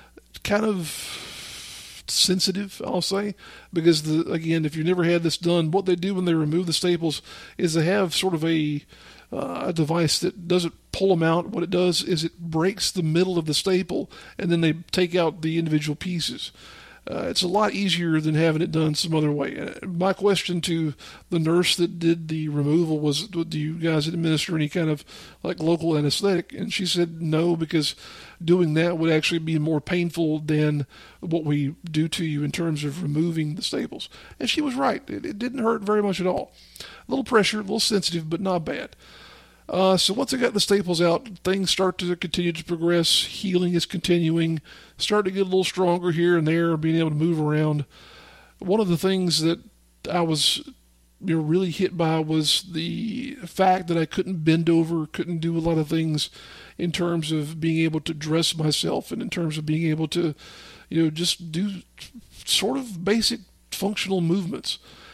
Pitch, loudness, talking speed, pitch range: 170 Hz, -23 LUFS, 195 wpm, 160-185 Hz